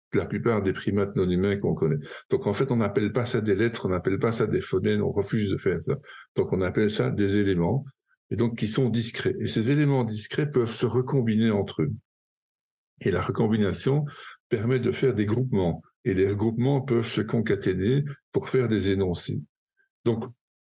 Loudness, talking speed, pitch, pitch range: -25 LUFS, 195 wpm, 120 Hz, 105-130 Hz